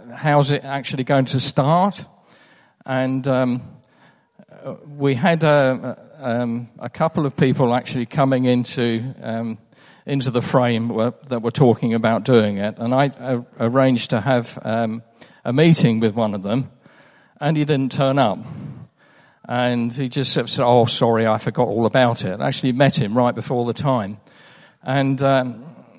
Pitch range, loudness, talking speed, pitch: 120-140 Hz, -19 LUFS, 170 wpm, 130 Hz